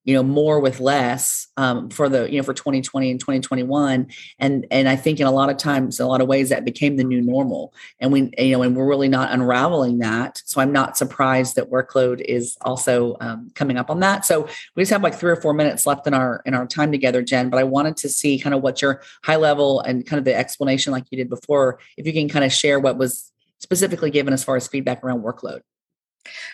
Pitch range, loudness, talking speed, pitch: 130-145 Hz, -19 LUFS, 245 wpm, 135 Hz